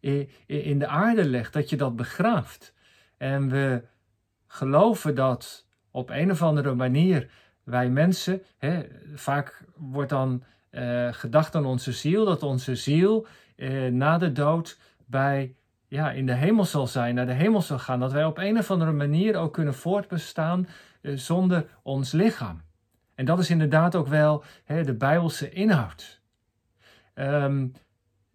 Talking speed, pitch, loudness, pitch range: 150 wpm, 140 Hz, -25 LUFS, 125-165 Hz